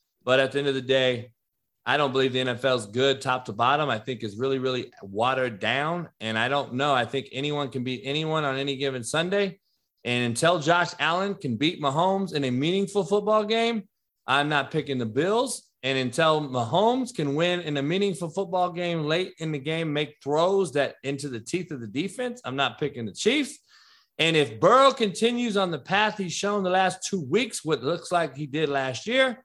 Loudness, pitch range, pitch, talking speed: -25 LUFS, 135-190 Hz, 150 Hz, 210 wpm